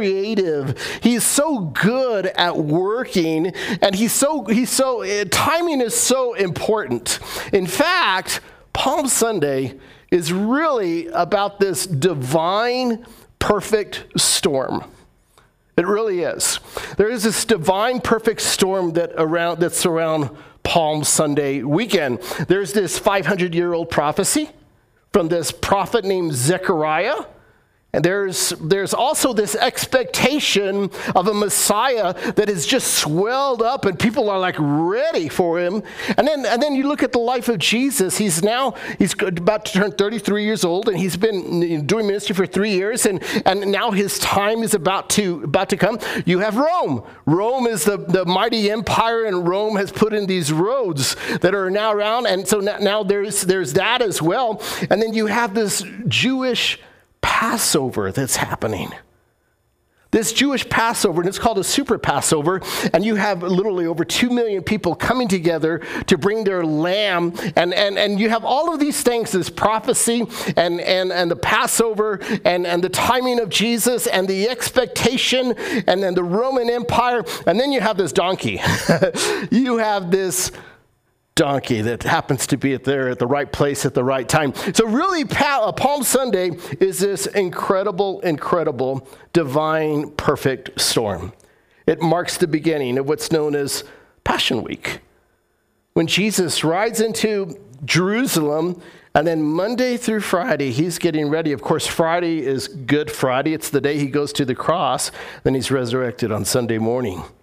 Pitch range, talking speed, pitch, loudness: 170-225 Hz, 155 wpm, 195 Hz, -19 LUFS